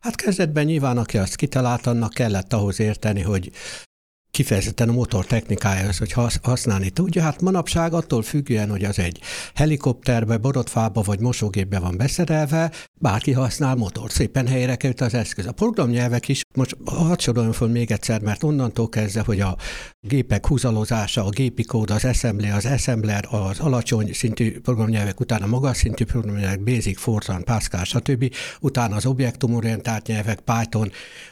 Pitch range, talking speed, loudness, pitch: 105-130 Hz, 150 wpm, -22 LUFS, 115 Hz